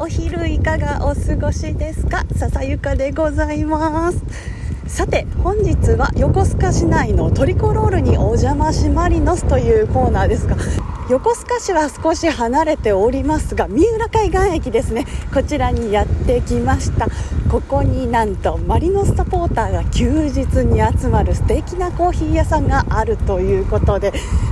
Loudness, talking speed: -17 LUFS, 305 characters per minute